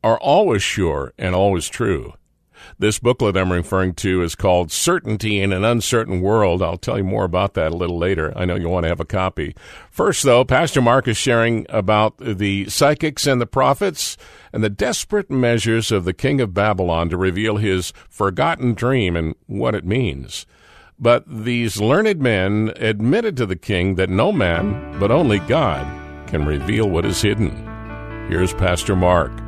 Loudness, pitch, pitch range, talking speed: -18 LUFS, 105 Hz, 90-115 Hz, 175 wpm